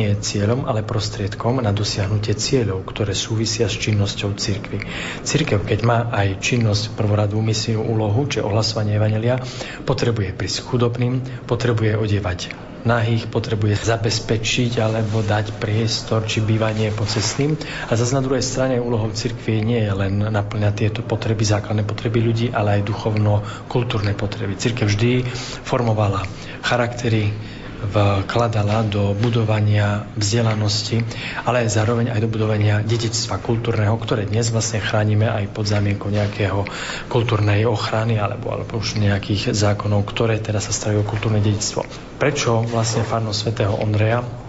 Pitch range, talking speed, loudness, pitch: 105-120 Hz, 130 wpm, -20 LUFS, 110 Hz